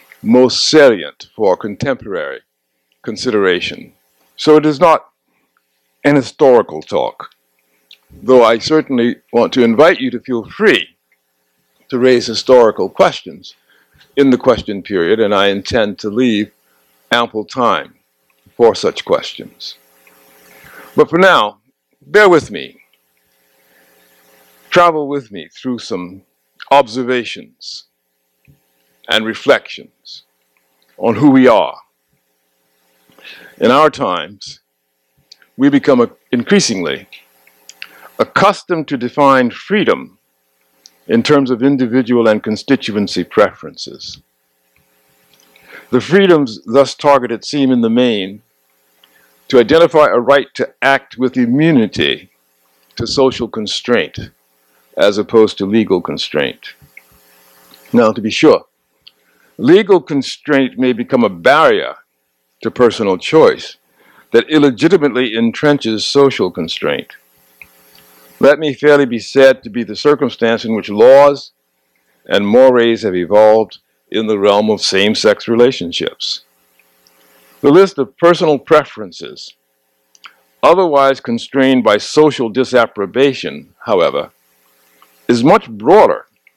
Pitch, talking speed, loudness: 110 Hz, 105 wpm, -12 LUFS